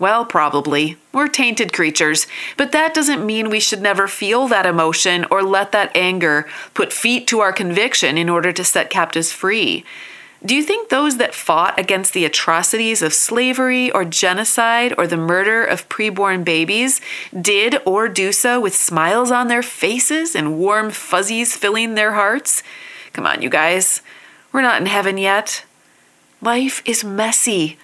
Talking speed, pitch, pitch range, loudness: 165 wpm, 210 Hz, 180-240 Hz, -16 LUFS